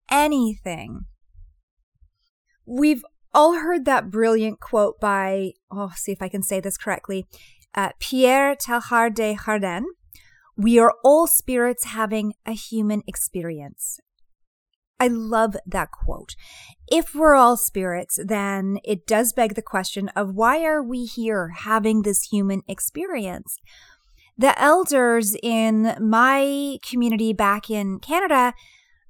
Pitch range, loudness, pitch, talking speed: 200-255 Hz, -21 LUFS, 225 Hz, 125 wpm